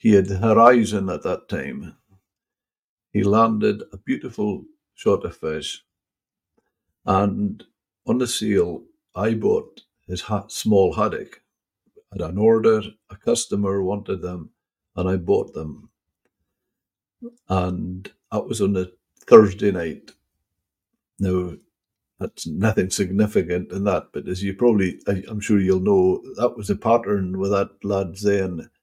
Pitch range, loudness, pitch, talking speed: 95-115 Hz, -21 LUFS, 100 Hz, 135 wpm